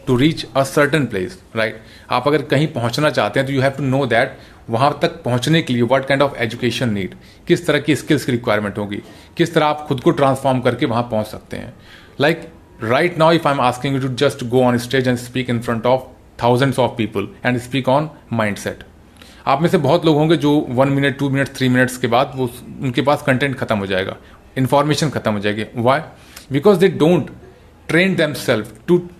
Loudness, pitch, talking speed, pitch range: -17 LUFS, 130 Hz, 220 wpm, 115-145 Hz